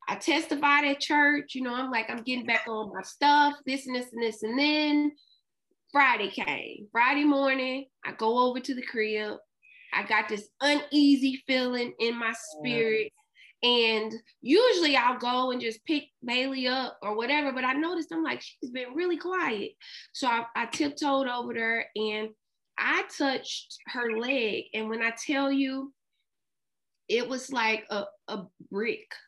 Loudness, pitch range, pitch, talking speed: -27 LUFS, 230-290 Hz, 260 Hz, 165 wpm